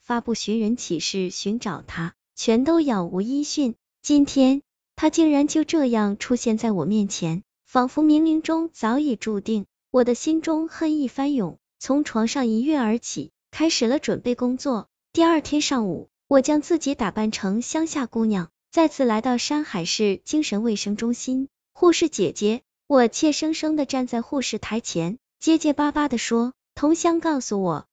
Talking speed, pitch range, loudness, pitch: 245 characters per minute, 220-300 Hz, -22 LUFS, 255 Hz